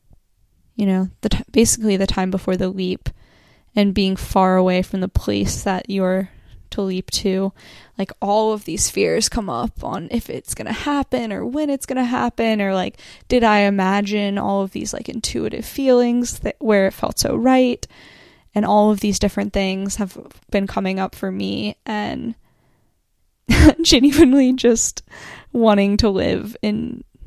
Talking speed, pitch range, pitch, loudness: 170 wpm, 190-230 Hz, 200 Hz, -19 LUFS